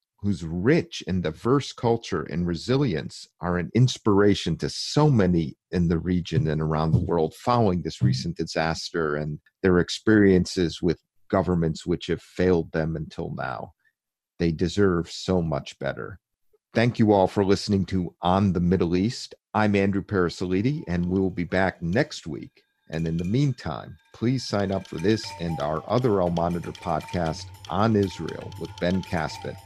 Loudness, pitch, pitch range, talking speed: -25 LUFS, 90 Hz, 85-100 Hz, 160 wpm